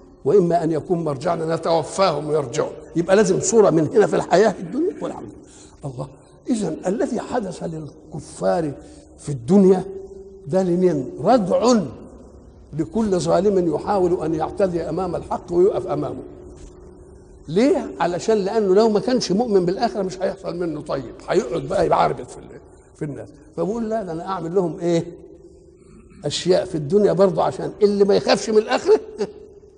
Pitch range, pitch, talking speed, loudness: 170-215 Hz, 190 Hz, 140 wpm, -20 LUFS